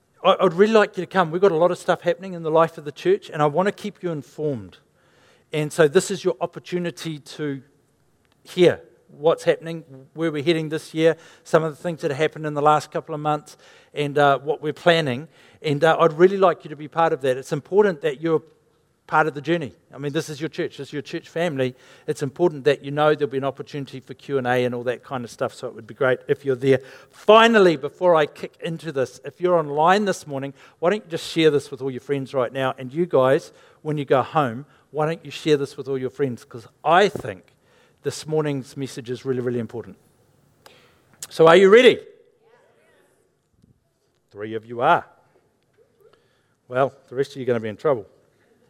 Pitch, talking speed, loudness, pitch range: 155 Hz, 225 wpm, -21 LUFS, 140-170 Hz